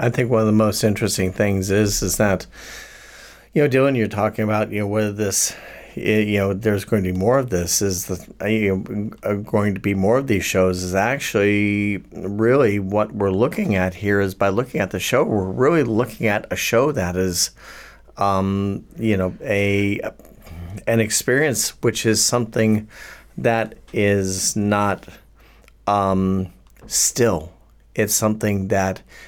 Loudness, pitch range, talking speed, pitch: -20 LUFS, 95-110 Hz, 160 wpm, 105 Hz